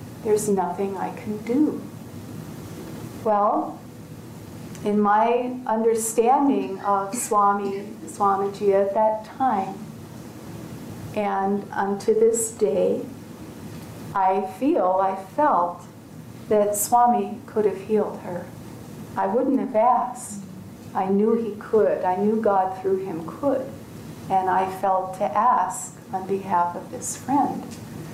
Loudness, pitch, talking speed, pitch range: -23 LUFS, 205 Hz, 115 wpm, 195-230 Hz